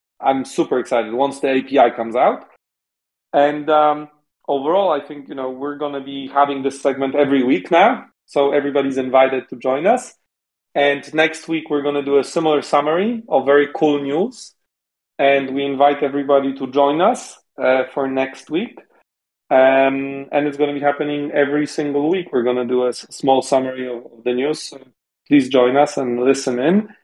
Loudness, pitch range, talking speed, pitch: -18 LUFS, 135-145 Hz, 175 wpm, 140 Hz